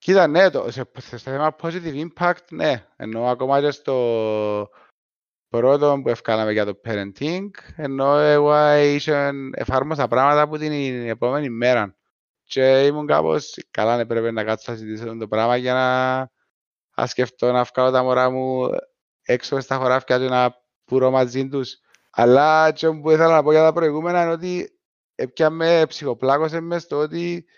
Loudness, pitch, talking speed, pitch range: -20 LUFS, 135 Hz, 160 wpm, 125-155 Hz